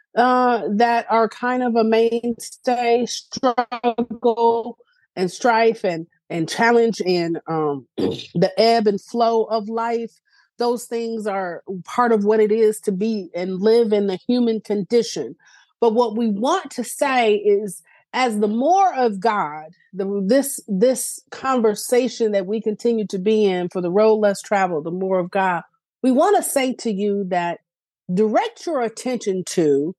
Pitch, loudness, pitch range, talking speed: 225 Hz, -20 LUFS, 195-240 Hz, 160 wpm